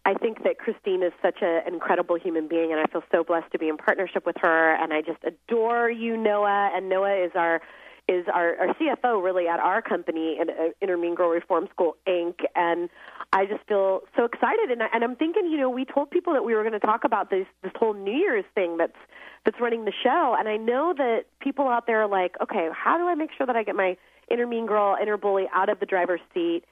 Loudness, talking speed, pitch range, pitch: -25 LUFS, 240 wpm, 175-235 Hz, 200 Hz